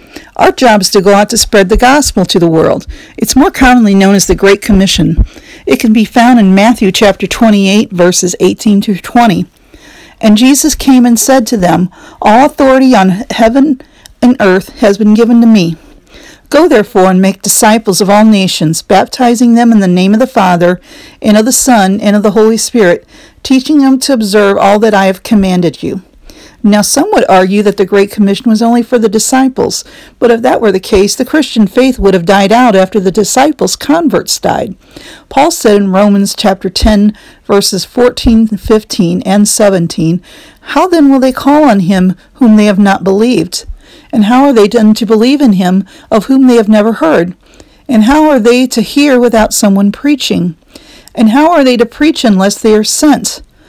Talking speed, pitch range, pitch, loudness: 195 wpm, 200-255 Hz, 220 Hz, -7 LUFS